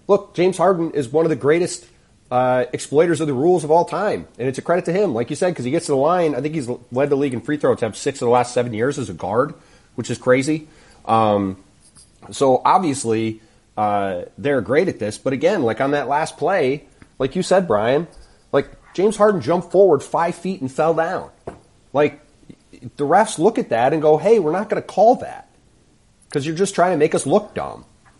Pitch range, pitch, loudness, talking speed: 125-170 Hz, 150 Hz, -19 LUFS, 225 wpm